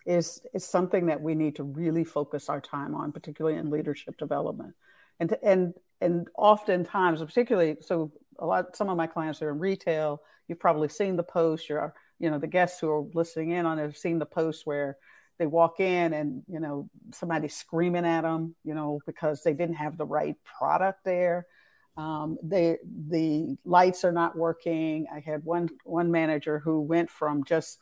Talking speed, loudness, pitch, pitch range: 190 wpm, -28 LUFS, 165 Hz, 155-175 Hz